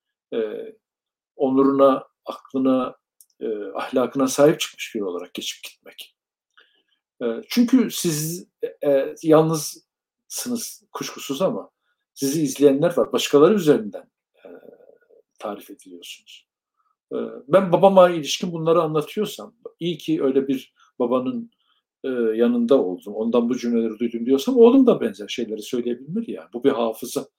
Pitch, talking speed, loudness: 160 Hz, 125 wpm, -21 LUFS